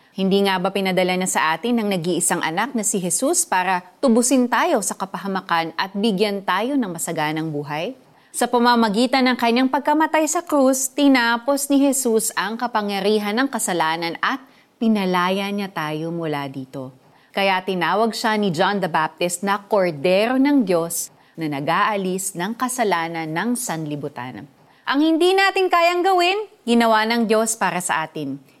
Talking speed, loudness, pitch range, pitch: 150 wpm, -20 LUFS, 175-250 Hz, 205 Hz